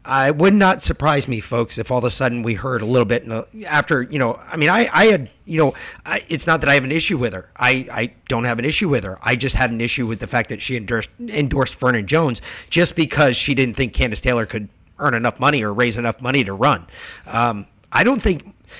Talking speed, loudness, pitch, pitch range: 250 wpm, -18 LUFS, 125 Hz, 115-150 Hz